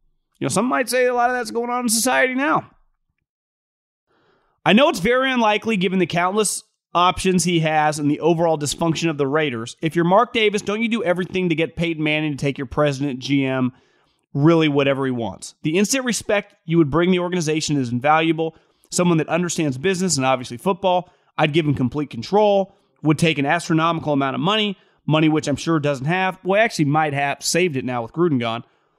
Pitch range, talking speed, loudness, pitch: 145-195 Hz, 205 wpm, -19 LUFS, 165 Hz